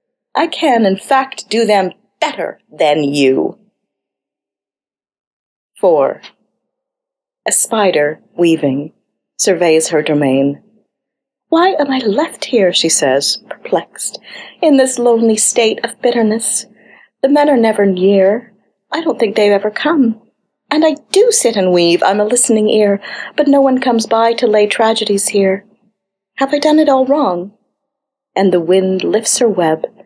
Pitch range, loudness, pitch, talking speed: 190-265 Hz, -13 LUFS, 215 Hz, 145 wpm